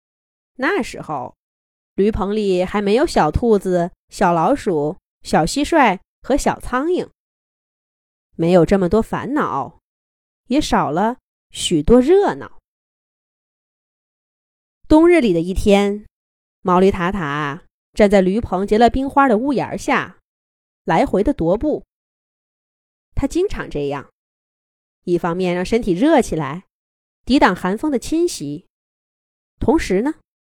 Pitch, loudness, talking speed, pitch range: 205 Hz, -17 LUFS, 170 characters per minute, 180-270 Hz